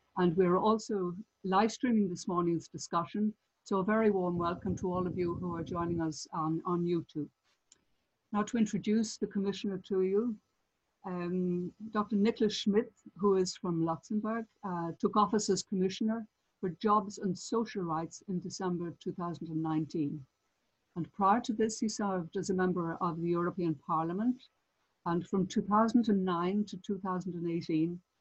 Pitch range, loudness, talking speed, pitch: 170-210 Hz, -33 LUFS, 150 wpm, 185 Hz